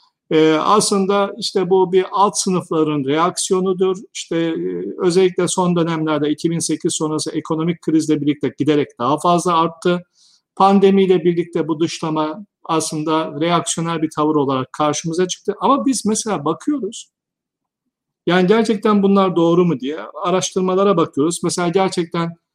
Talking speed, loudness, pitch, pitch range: 120 wpm, -17 LUFS, 175 Hz, 160-195 Hz